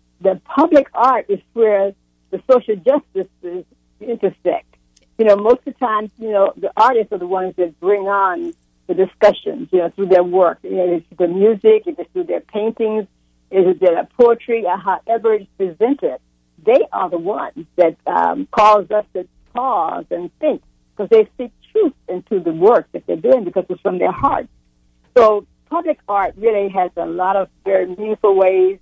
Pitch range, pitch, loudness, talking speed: 180-235 Hz, 200 Hz, -17 LUFS, 180 wpm